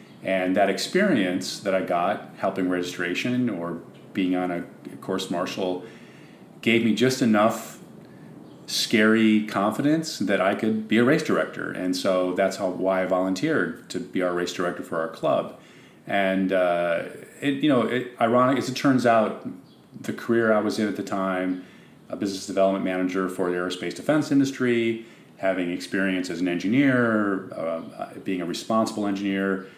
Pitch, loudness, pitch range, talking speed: 95 Hz, -24 LUFS, 90-115 Hz, 160 wpm